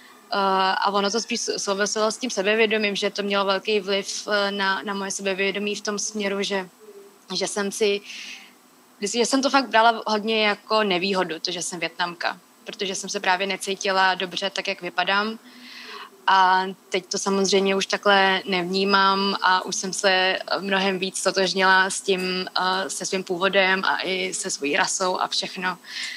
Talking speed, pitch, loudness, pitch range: 160 wpm, 195 Hz, -22 LUFS, 190-205 Hz